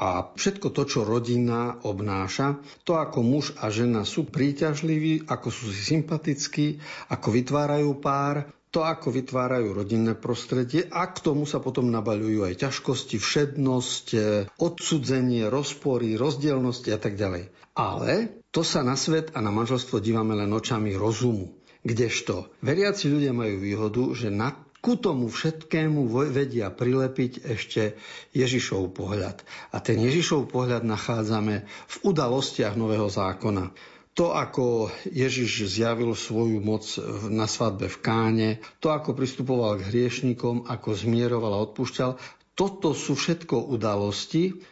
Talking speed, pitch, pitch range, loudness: 135 wpm, 125 Hz, 110-145 Hz, -26 LUFS